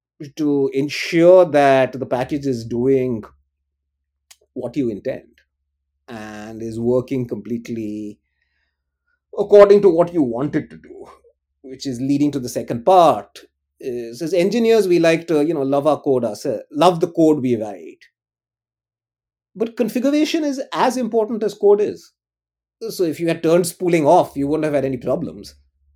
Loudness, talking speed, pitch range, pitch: -18 LUFS, 155 wpm, 115-180 Hz, 140 Hz